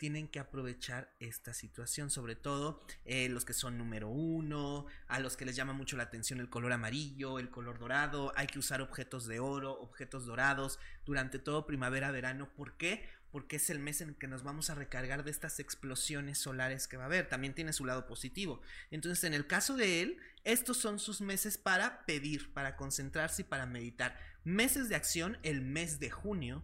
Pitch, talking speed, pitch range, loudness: 140 Hz, 200 wpm, 130-155 Hz, -38 LUFS